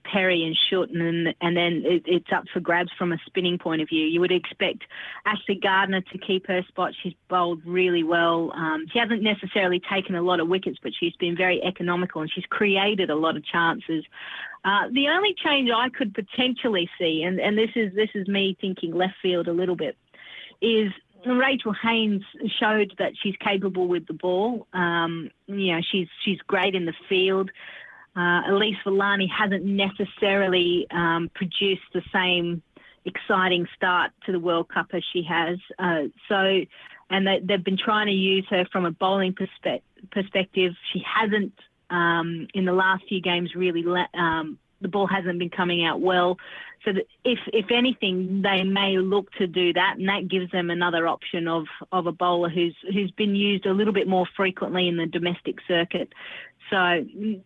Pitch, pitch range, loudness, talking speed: 185 Hz, 175-200 Hz, -24 LUFS, 185 wpm